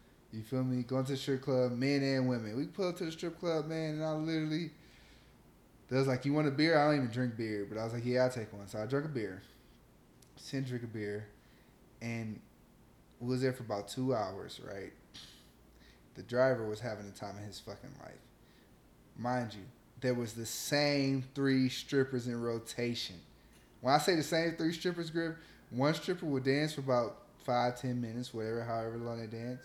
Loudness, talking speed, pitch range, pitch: -35 LUFS, 205 wpm, 115-140 Hz, 125 Hz